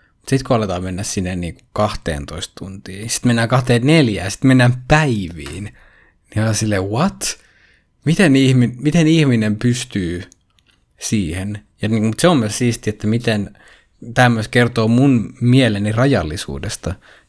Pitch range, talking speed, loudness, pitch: 95-125 Hz, 130 wpm, -17 LUFS, 110 Hz